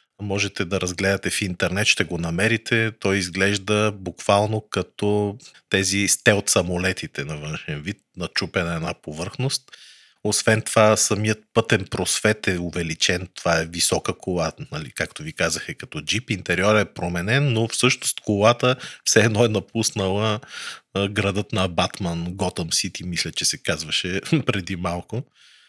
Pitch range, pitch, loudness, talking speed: 90-110 Hz, 100 Hz, -22 LUFS, 145 wpm